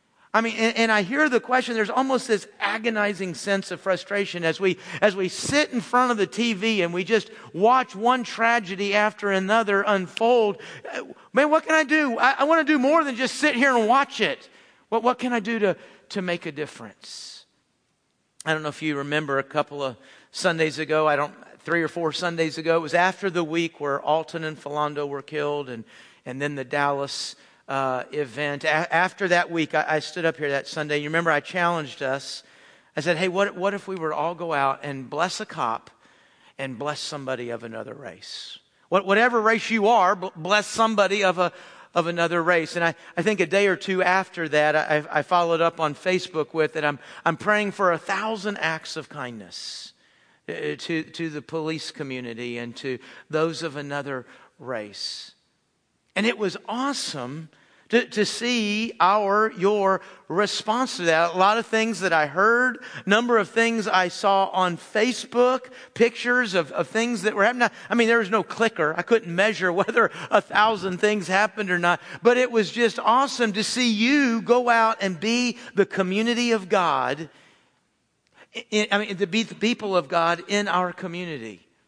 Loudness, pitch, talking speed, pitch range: -23 LUFS, 190 Hz, 190 wpm, 155-225 Hz